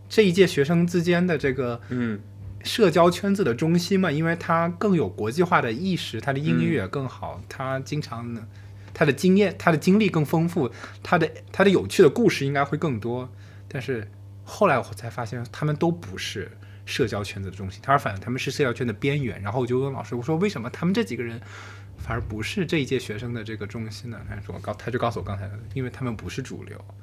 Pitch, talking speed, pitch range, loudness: 120 Hz, 330 characters per minute, 105-160 Hz, -24 LUFS